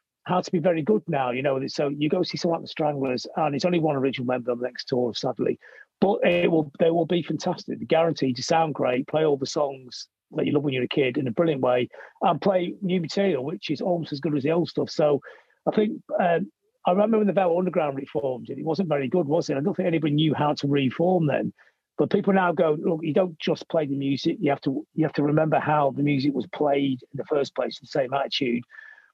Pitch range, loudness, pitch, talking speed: 140-180 Hz, -25 LUFS, 155 Hz, 255 wpm